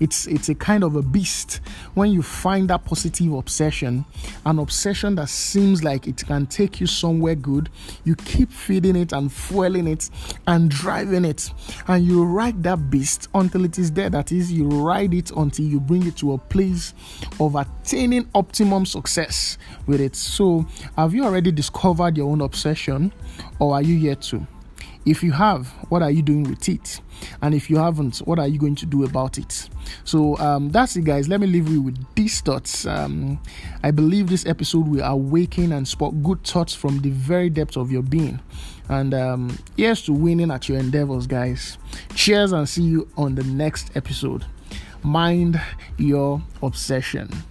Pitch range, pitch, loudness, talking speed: 140-175 Hz, 155 Hz, -21 LUFS, 185 wpm